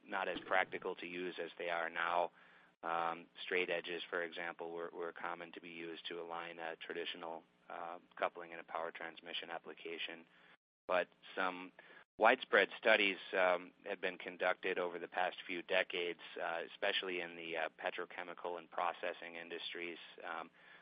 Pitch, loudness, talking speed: 85 Hz, -40 LUFS, 155 wpm